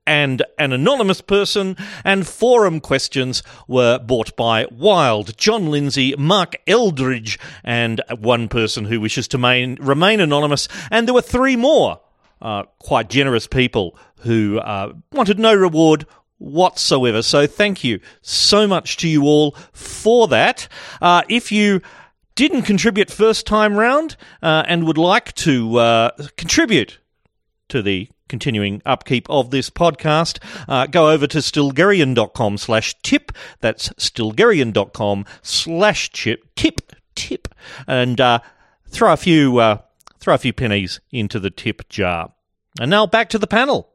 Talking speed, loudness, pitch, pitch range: 140 wpm, -16 LUFS, 145 Hz, 120-195 Hz